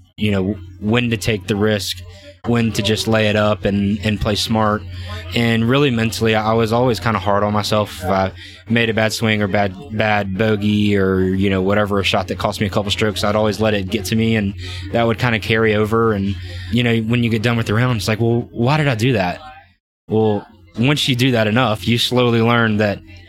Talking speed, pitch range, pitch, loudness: 235 wpm, 100-115 Hz, 110 Hz, -17 LUFS